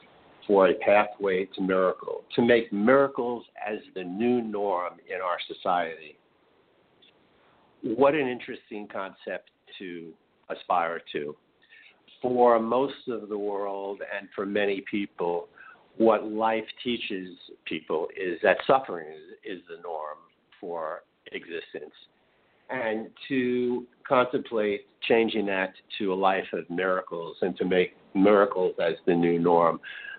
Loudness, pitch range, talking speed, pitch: -27 LUFS, 95-135 Hz, 125 wpm, 110 Hz